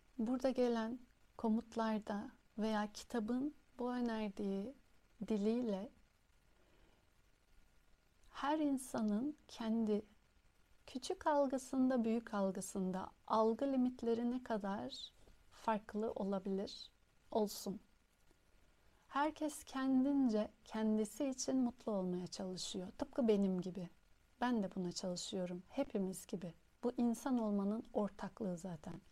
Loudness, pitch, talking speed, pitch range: -40 LUFS, 220 Hz, 90 wpm, 195-250 Hz